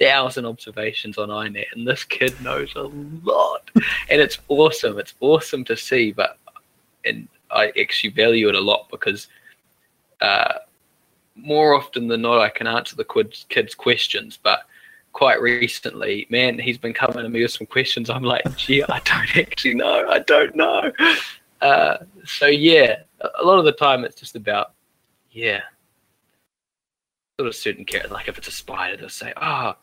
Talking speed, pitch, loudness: 170 wpm, 145 Hz, -19 LUFS